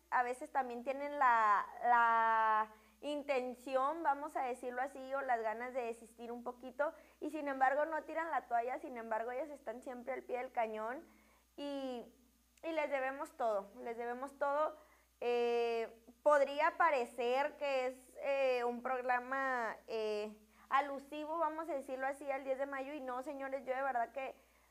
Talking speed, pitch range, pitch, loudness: 165 wpm, 240-285 Hz, 260 Hz, -38 LUFS